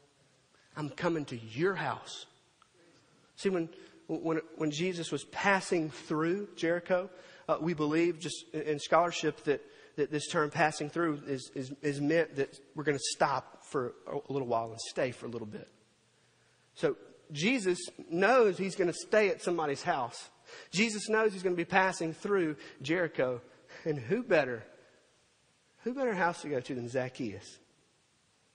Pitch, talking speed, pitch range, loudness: 165 Hz, 160 wpm, 145-185 Hz, -32 LUFS